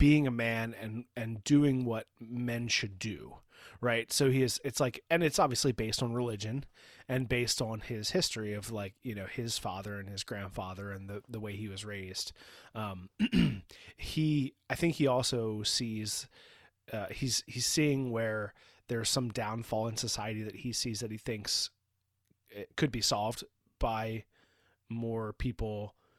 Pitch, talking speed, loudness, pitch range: 115 Hz, 165 wpm, -33 LUFS, 105-125 Hz